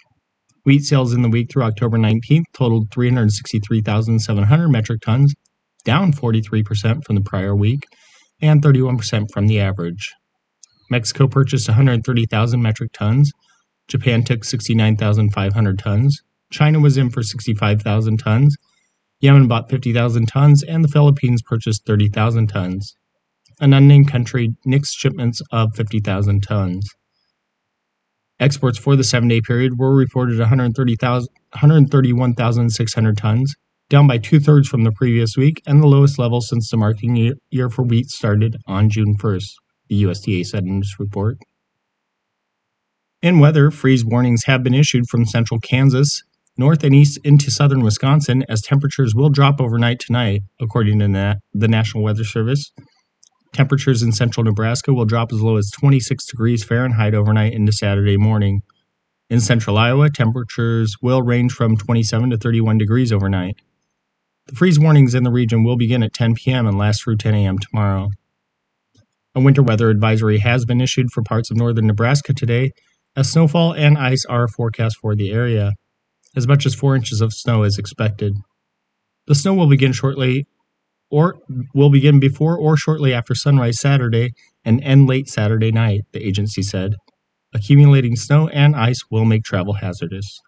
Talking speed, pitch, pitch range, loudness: 150 wpm, 120 Hz, 110-135 Hz, -16 LUFS